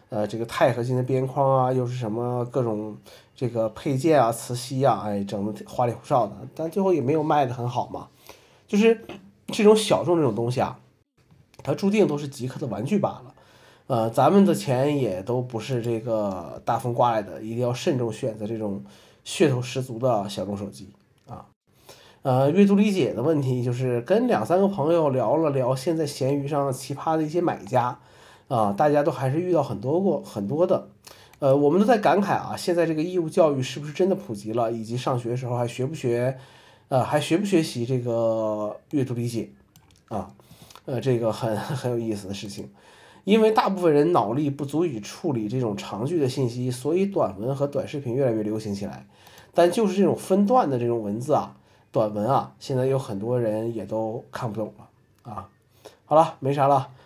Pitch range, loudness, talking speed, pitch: 115-150 Hz, -24 LUFS, 290 characters per minute, 130 Hz